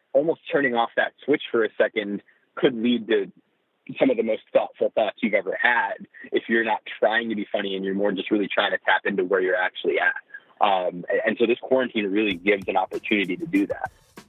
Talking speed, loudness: 220 wpm, -23 LUFS